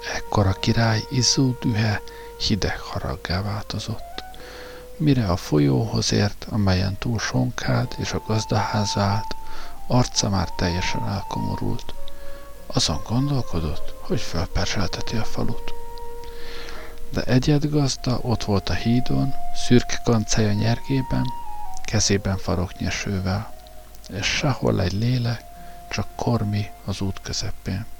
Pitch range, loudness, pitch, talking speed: 95-125 Hz, -23 LUFS, 110 Hz, 105 wpm